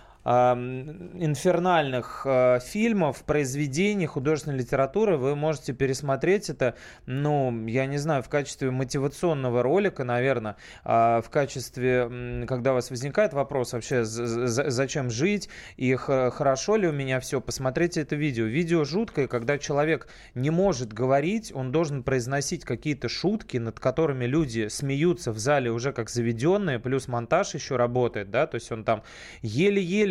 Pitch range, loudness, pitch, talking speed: 125-160 Hz, -26 LUFS, 135 Hz, 135 wpm